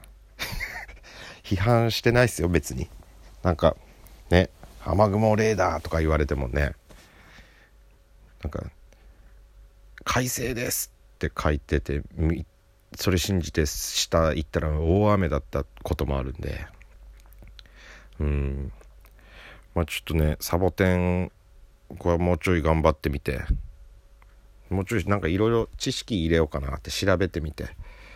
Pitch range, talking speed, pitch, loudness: 75-95 Hz, 255 characters per minute, 85 Hz, -25 LUFS